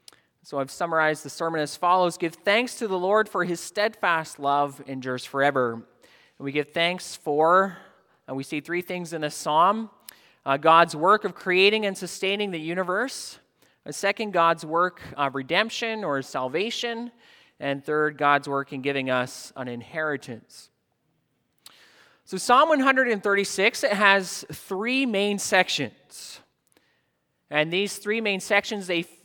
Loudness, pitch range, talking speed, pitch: -24 LUFS, 145-200 Hz, 145 wpm, 175 Hz